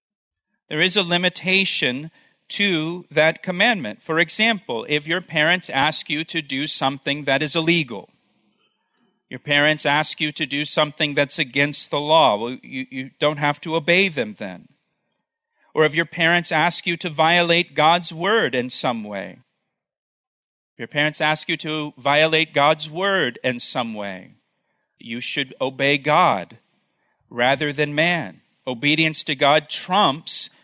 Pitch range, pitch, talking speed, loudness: 145-175 Hz, 155 Hz, 150 wpm, -20 LUFS